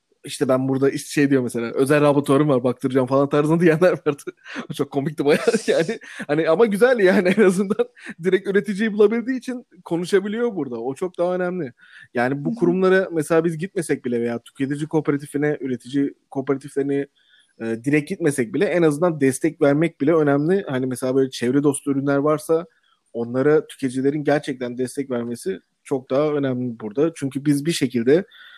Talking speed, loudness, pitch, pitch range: 165 wpm, -21 LUFS, 145 Hz, 135-180 Hz